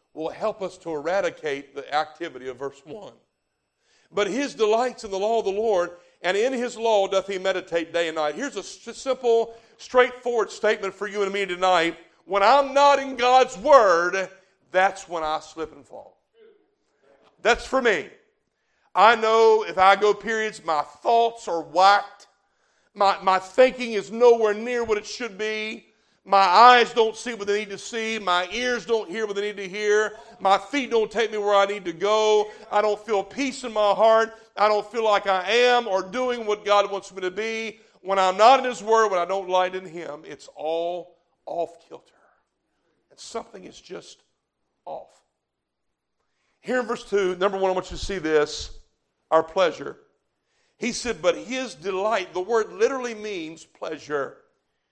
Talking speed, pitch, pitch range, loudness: 185 wpm, 210 Hz, 185-230 Hz, -22 LUFS